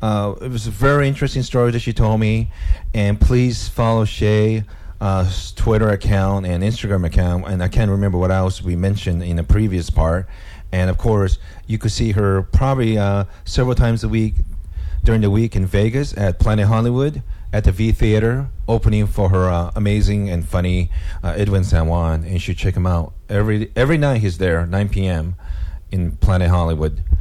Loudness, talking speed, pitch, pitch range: -18 LUFS, 185 wpm, 100 Hz, 90-110 Hz